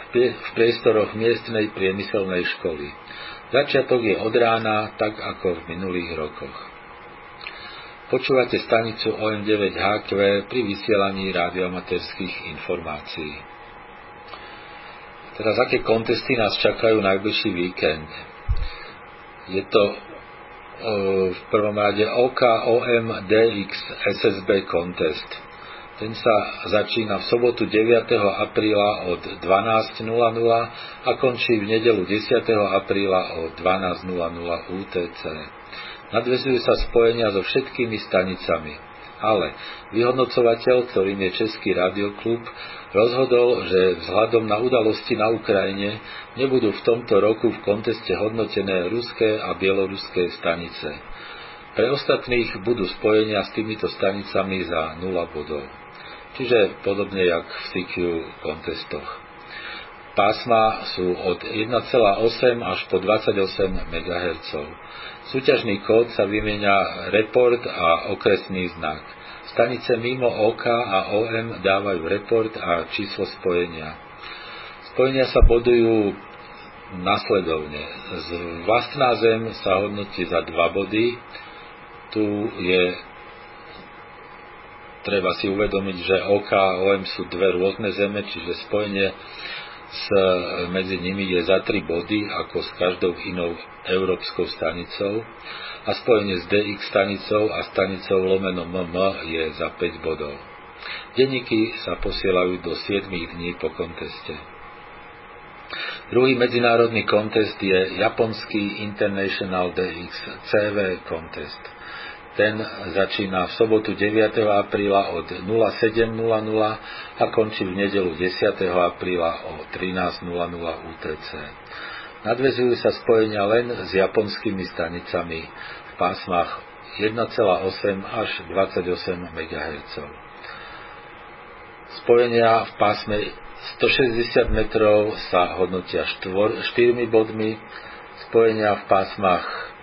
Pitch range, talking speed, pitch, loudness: 95-115 Hz, 105 wpm, 100 Hz, -22 LUFS